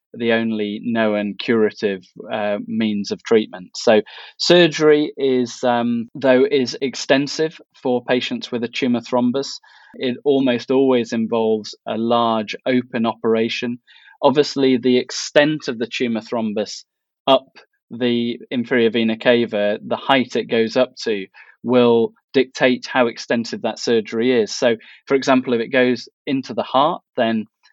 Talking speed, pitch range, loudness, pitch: 140 wpm, 115-130 Hz, -19 LUFS, 120 Hz